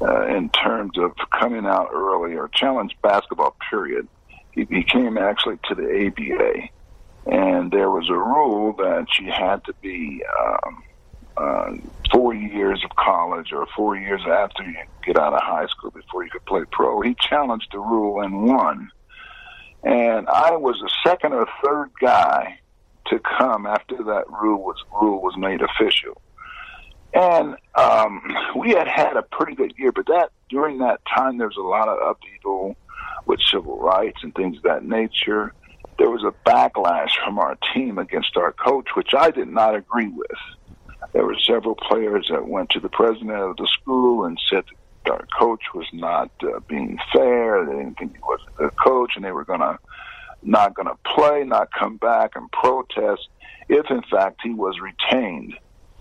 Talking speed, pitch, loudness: 175 wpm, 270 Hz, -20 LUFS